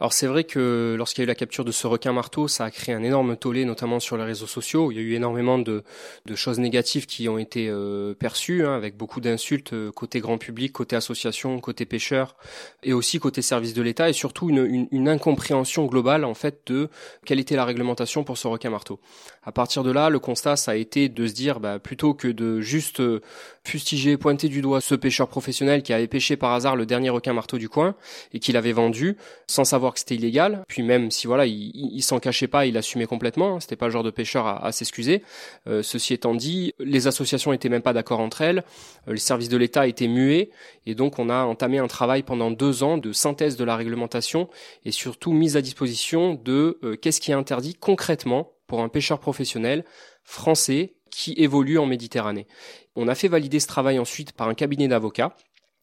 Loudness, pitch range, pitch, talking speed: -23 LUFS, 120-145 Hz, 130 Hz, 220 wpm